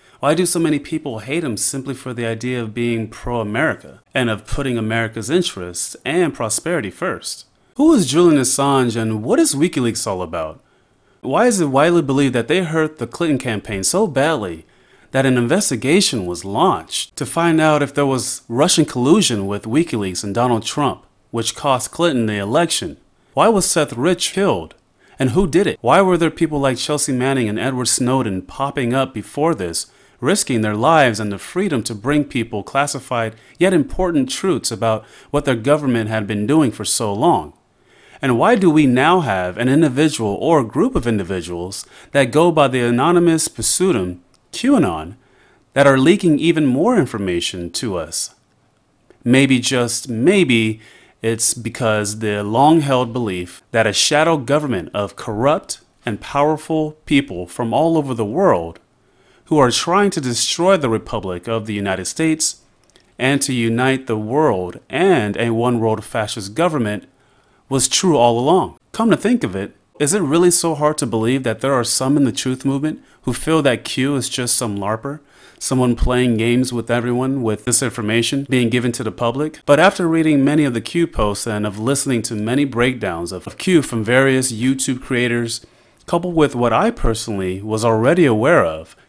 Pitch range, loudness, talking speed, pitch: 110-150 Hz, -17 LUFS, 175 wpm, 125 Hz